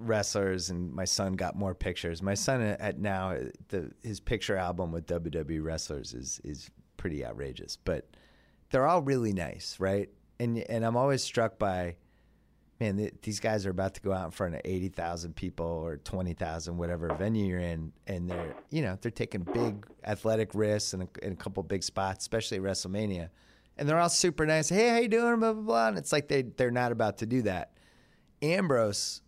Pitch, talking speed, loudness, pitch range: 100 Hz, 200 wpm, -31 LUFS, 90-115 Hz